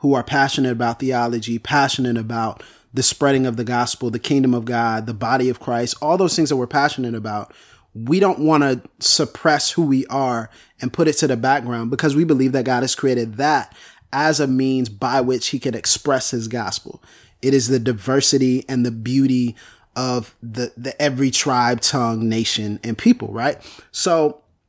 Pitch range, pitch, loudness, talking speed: 120-140 Hz, 130 Hz, -19 LUFS, 185 wpm